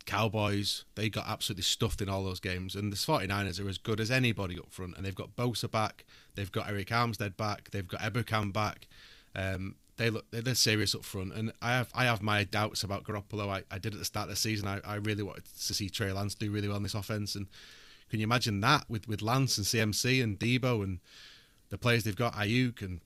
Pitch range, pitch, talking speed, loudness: 100-115 Hz, 105 Hz, 235 wpm, -32 LUFS